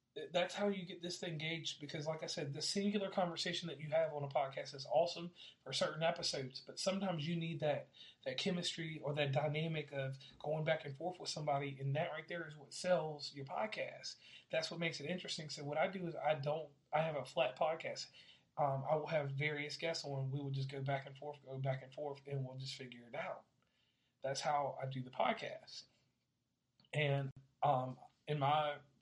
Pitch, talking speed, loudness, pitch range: 150 Hz, 210 wpm, -41 LUFS, 140-165 Hz